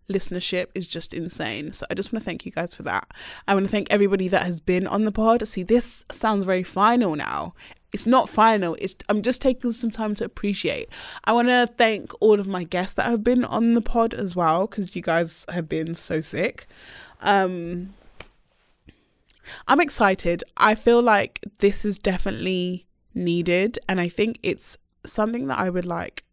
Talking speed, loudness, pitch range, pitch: 190 wpm, -23 LUFS, 180-230 Hz, 200 Hz